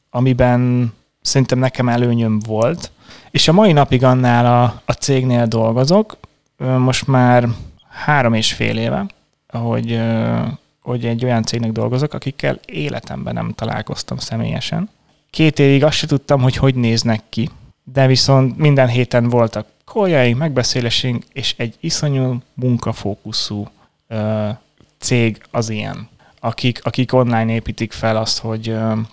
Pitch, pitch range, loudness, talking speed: 120 Hz, 115-135 Hz, -16 LUFS, 130 wpm